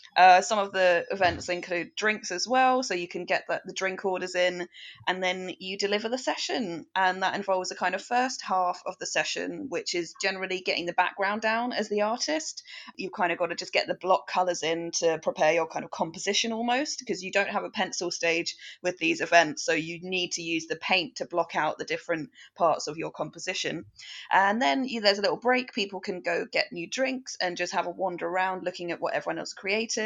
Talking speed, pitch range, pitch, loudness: 230 wpm, 175-210 Hz, 185 Hz, -27 LUFS